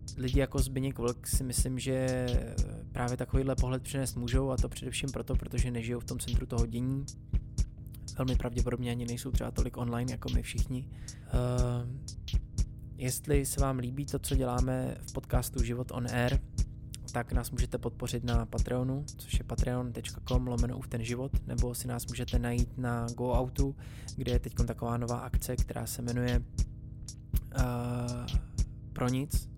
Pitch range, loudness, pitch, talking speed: 120-125 Hz, -34 LUFS, 120 Hz, 160 wpm